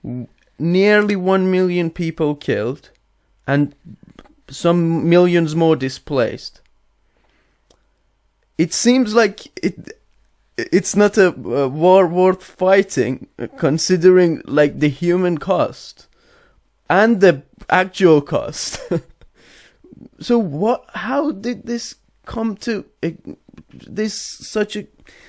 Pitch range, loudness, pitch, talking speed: 160-210 Hz, -17 LUFS, 185 Hz, 95 wpm